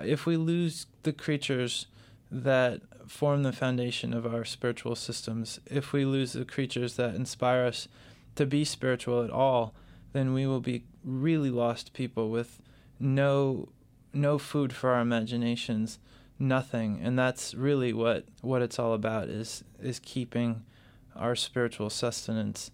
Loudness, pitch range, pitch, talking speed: -30 LUFS, 115-135 Hz, 125 Hz, 145 wpm